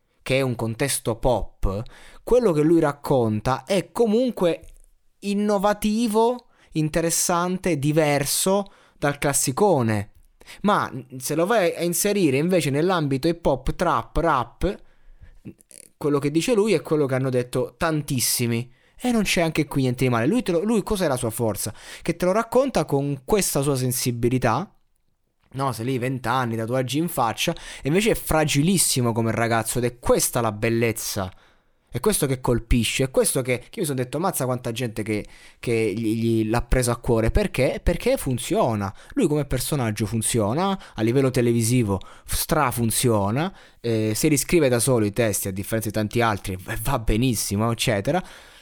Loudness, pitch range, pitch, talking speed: -22 LUFS, 115-170 Hz, 135 Hz, 160 wpm